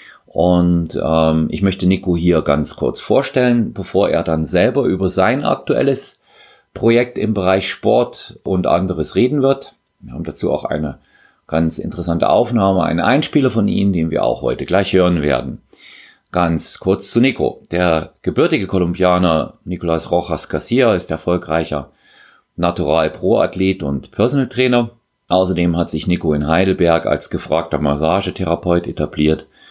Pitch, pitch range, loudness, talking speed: 90 Hz, 80-95 Hz, -16 LUFS, 140 wpm